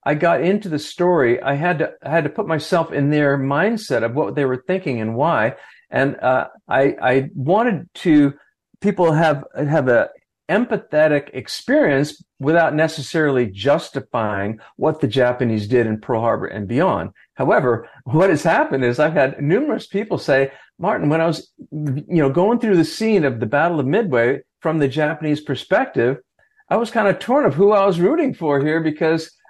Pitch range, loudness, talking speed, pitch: 140-175 Hz, -18 LUFS, 180 wpm, 155 Hz